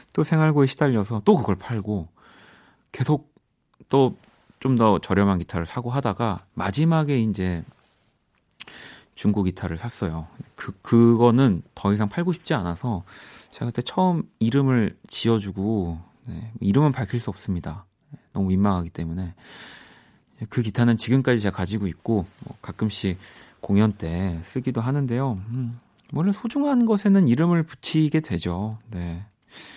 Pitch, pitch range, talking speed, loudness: 115 Hz, 95-135 Hz, 280 characters per minute, -23 LUFS